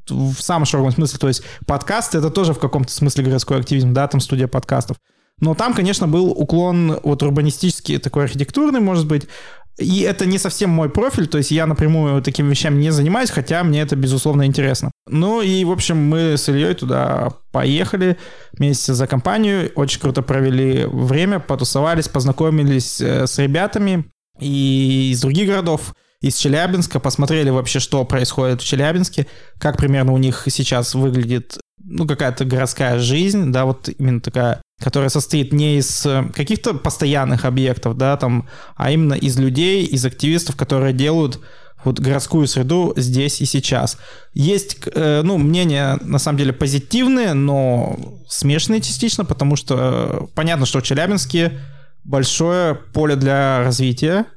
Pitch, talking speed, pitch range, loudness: 140 Hz, 150 wpm, 135-160 Hz, -17 LUFS